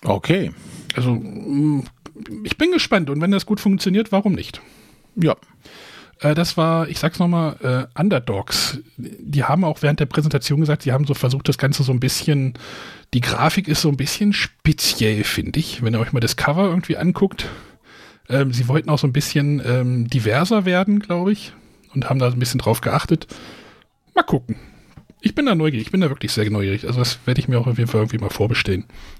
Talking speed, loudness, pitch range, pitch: 195 wpm, -19 LUFS, 125-170 Hz, 145 Hz